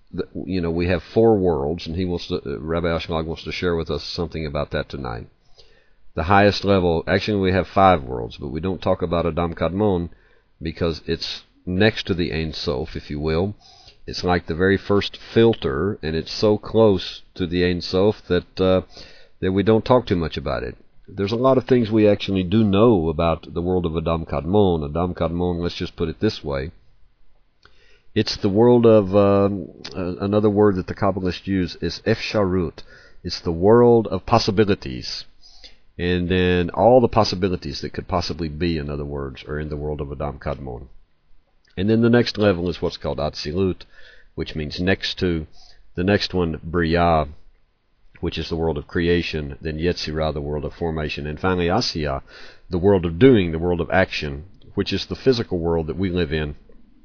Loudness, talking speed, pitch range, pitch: -21 LUFS, 190 wpm, 80-100 Hz, 90 Hz